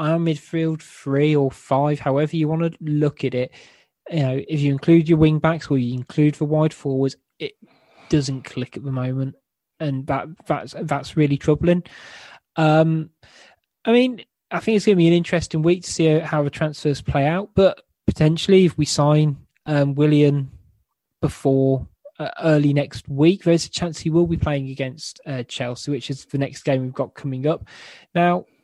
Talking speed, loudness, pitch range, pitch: 185 wpm, -20 LUFS, 135-165 Hz, 150 Hz